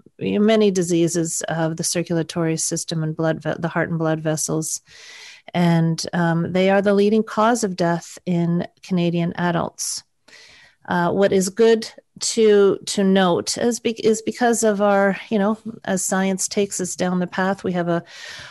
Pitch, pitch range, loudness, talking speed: 185 Hz, 170-210 Hz, -20 LUFS, 165 wpm